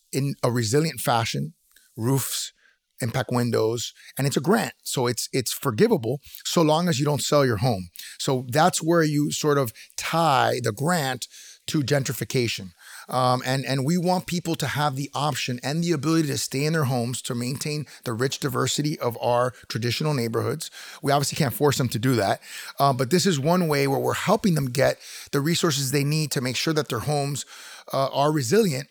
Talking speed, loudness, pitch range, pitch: 195 wpm, -24 LUFS, 125-155 Hz, 140 Hz